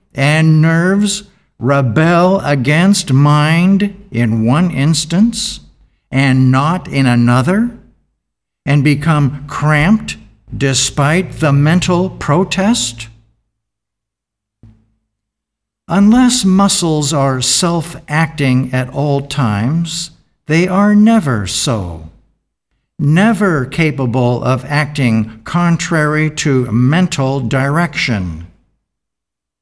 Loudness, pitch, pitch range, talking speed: -13 LUFS, 145 Hz, 120-175 Hz, 80 wpm